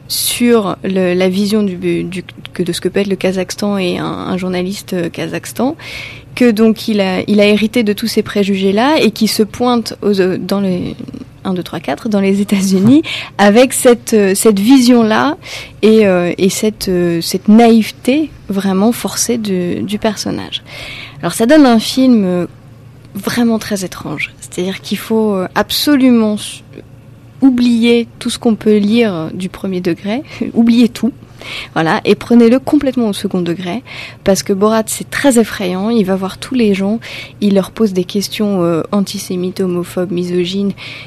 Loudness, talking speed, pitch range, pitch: -13 LUFS, 150 wpm, 180-225 Hz, 200 Hz